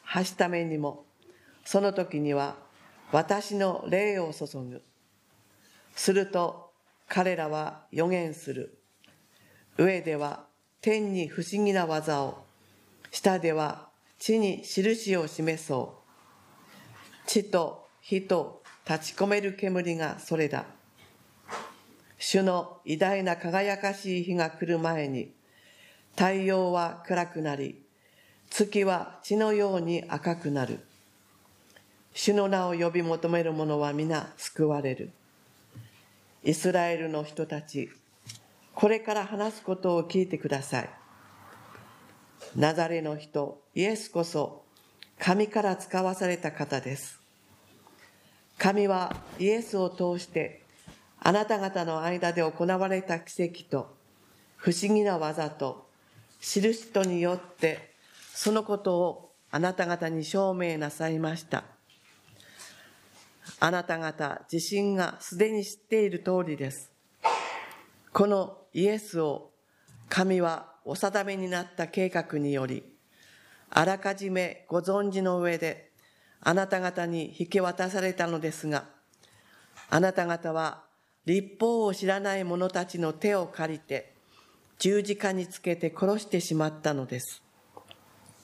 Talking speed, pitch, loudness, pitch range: 215 characters per minute, 175 Hz, -29 LUFS, 155-190 Hz